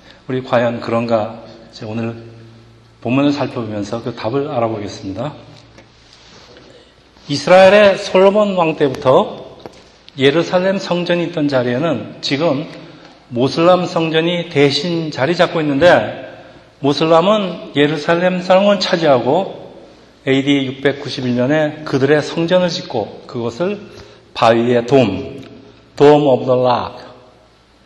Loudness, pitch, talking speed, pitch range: -15 LUFS, 140 Hz, 230 characters per minute, 120-170 Hz